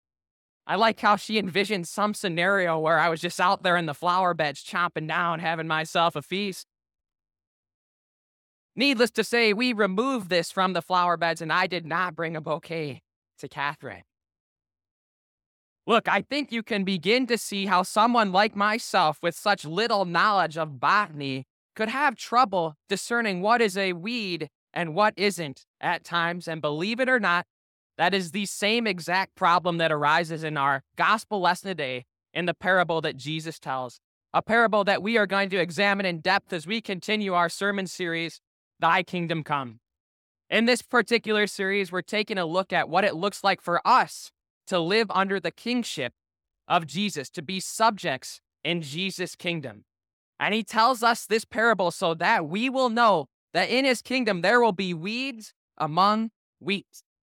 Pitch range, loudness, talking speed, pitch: 160-210 Hz, -25 LUFS, 170 wpm, 180 Hz